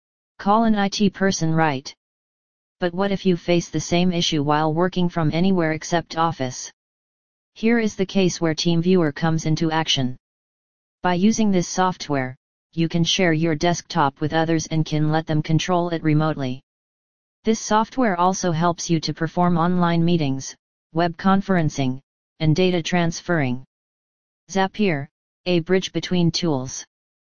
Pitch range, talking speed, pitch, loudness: 155-180 Hz, 145 wpm, 170 Hz, -21 LUFS